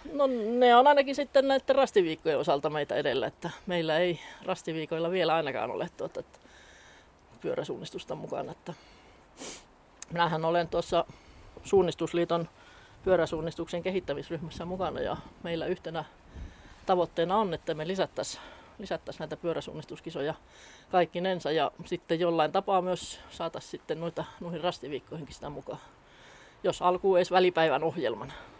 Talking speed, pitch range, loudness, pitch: 120 wpm, 165-195 Hz, -29 LUFS, 175 Hz